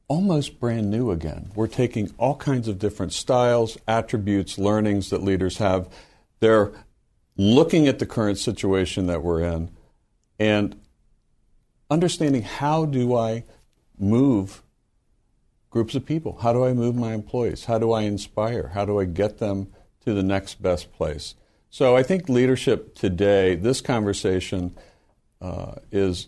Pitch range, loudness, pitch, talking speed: 95-120 Hz, -23 LUFS, 110 Hz, 145 wpm